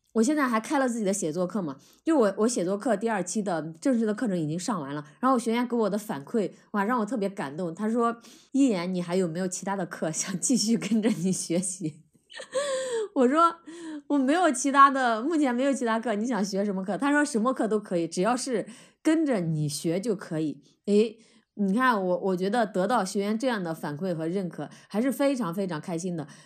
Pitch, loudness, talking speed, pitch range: 215 Hz, -27 LUFS, 310 characters per minute, 180-255 Hz